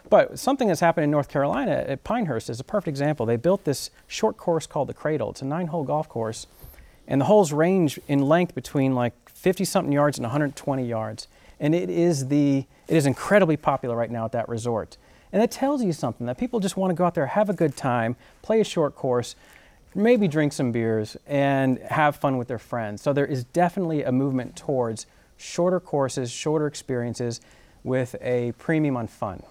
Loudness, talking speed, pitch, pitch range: -24 LUFS, 205 wpm, 145 Hz, 125-170 Hz